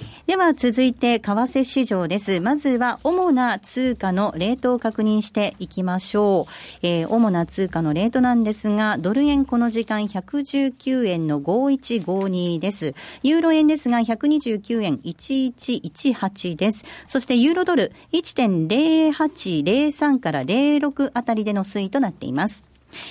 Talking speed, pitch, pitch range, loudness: 240 characters per minute, 235 Hz, 195-270 Hz, -21 LUFS